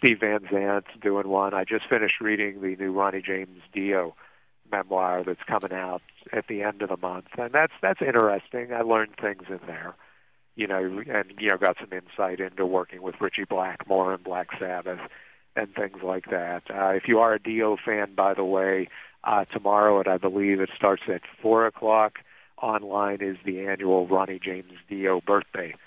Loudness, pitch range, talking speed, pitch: -26 LUFS, 95-105 Hz, 190 wpm, 95 Hz